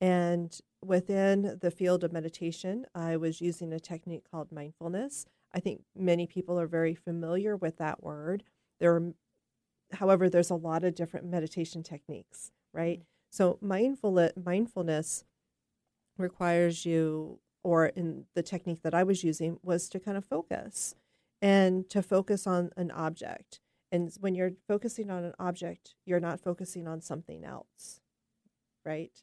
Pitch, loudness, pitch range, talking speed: 175 Hz, -32 LUFS, 165-185 Hz, 145 wpm